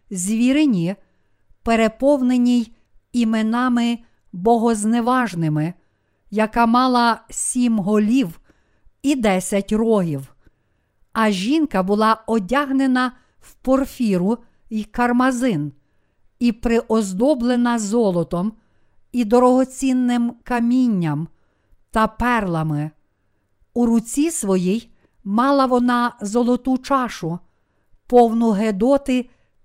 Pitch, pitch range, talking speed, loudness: 230 Hz, 190-245 Hz, 75 wpm, -19 LUFS